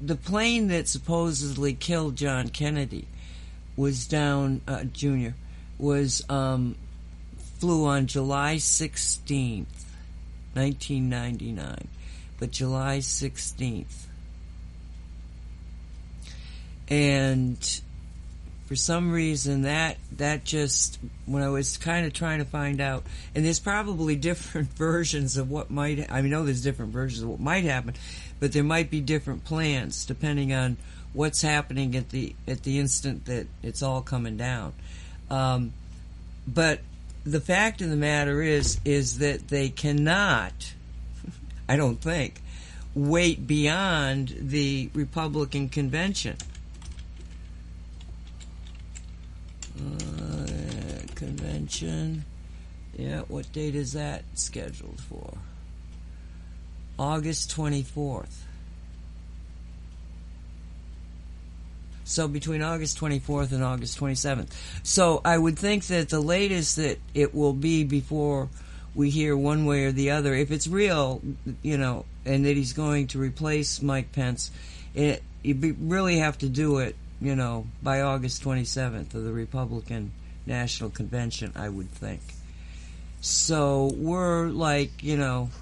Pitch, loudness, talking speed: 135 Hz, -27 LUFS, 125 wpm